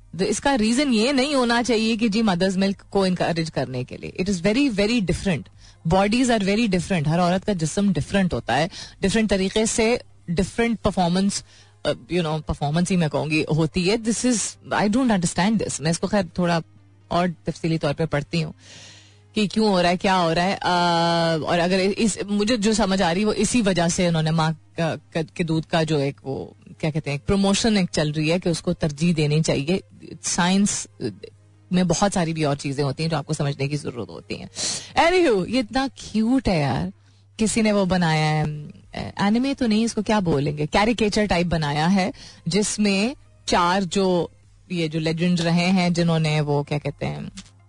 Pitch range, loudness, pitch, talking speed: 155-205 Hz, -22 LUFS, 175 Hz, 195 wpm